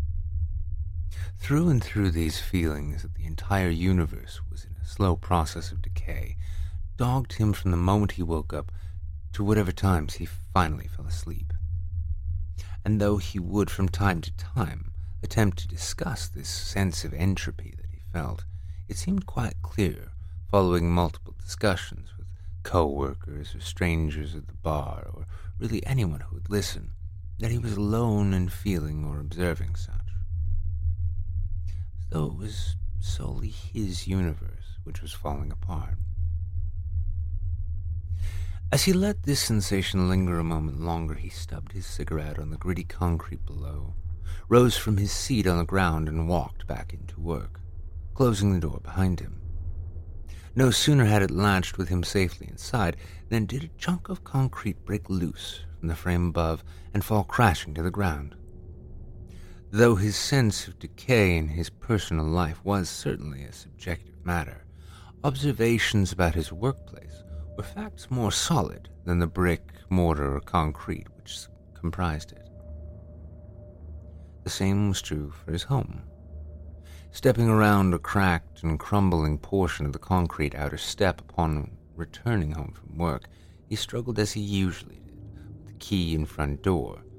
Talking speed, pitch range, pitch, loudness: 150 wpm, 80-95 Hz, 85 Hz, -28 LUFS